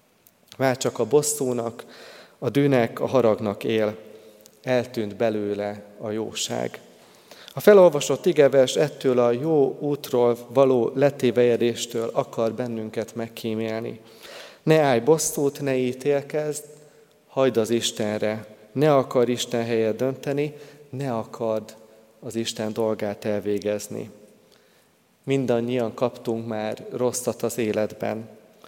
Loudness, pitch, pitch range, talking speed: -23 LUFS, 120 Hz, 110-135 Hz, 105 wpm